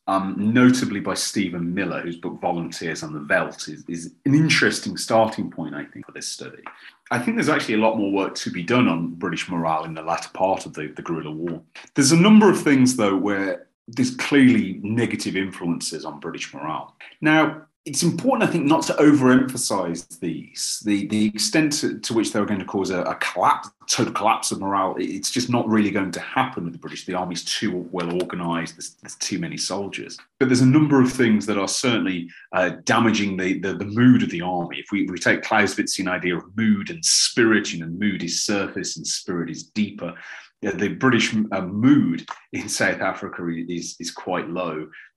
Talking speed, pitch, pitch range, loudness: 205 wpm, 100 Hz, 90-130 Hz, -21 LUFS